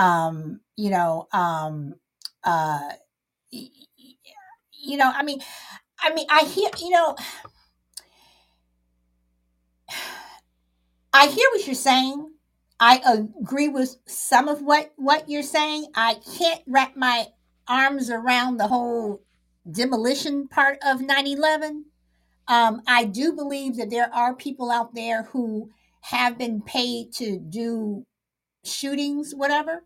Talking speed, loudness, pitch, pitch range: 120 wpm, -22 LUFS, 250 Hz, 215-285 Hz